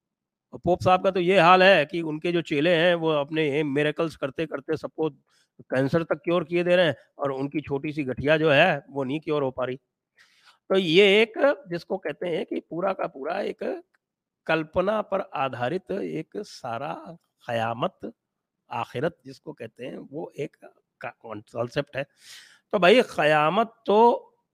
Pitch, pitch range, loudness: 155 Hz, 140-180 Hz, -24 LUFS